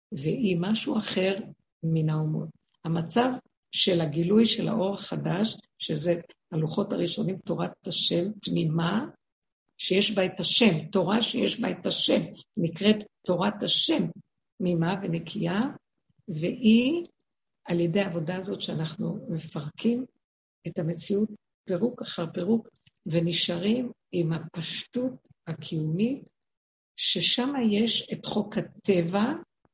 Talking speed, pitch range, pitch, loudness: 105 wpm, 170-220 Hz, 190 Hz, -27 LUFS